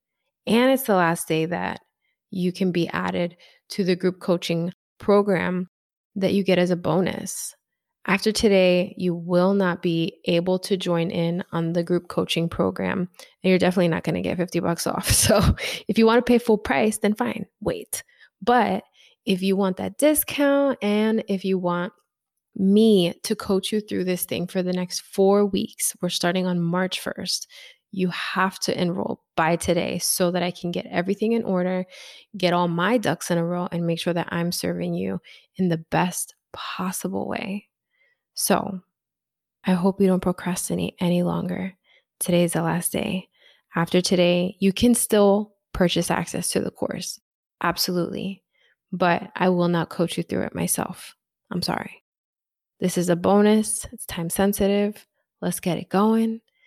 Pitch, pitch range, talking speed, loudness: 185 Hz, 175-205 Hz, 170 wpm, -23 LUFS